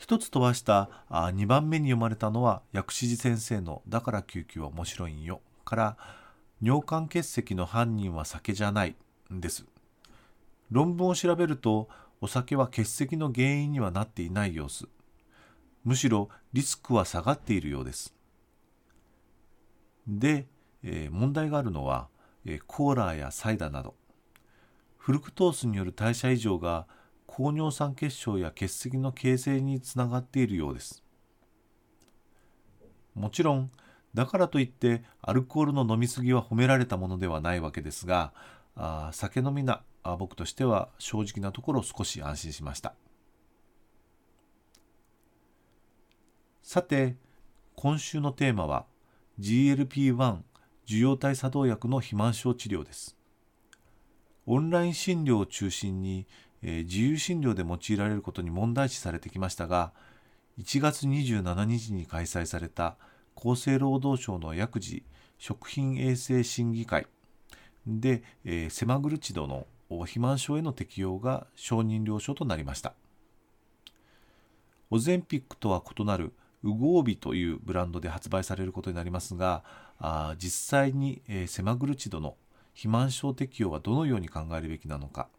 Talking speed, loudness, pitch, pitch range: 275 characters per minute, -30 LUFS, 115 Hz, 90-130 Hz